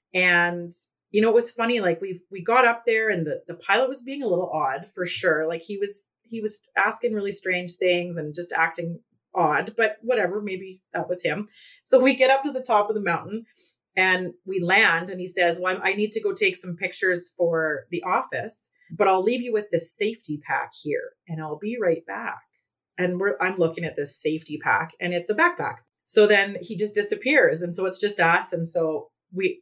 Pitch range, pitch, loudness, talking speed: 175-220 Hz, 190 Hz, -23 LUFS, 220 wpm